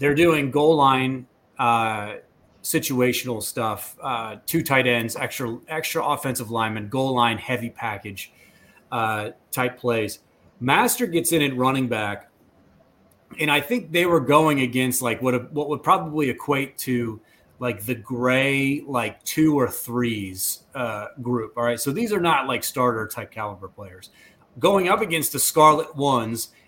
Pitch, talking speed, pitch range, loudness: 125 Hz, 155 wpm, 115-145 Hz, -22 LUFS